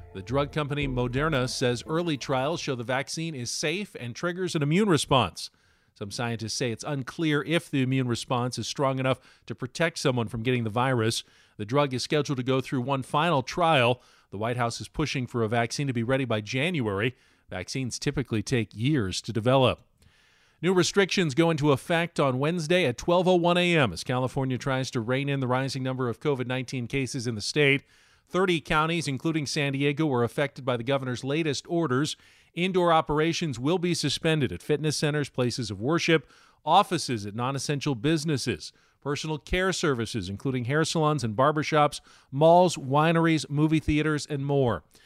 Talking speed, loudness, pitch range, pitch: 175 wpm, -26 LUFS, 125-155 Hz, 140 Hz